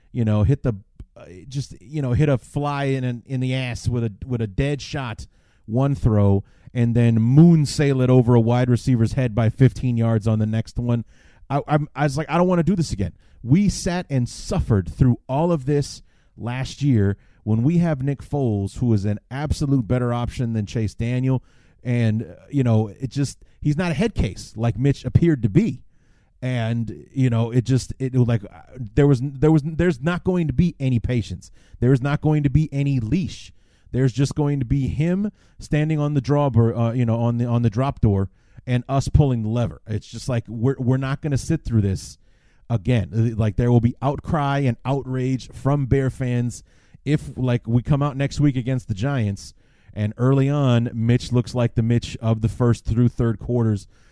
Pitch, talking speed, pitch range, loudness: 125 Hz, 210 wpm, 115-140 Hz, -21 LUFS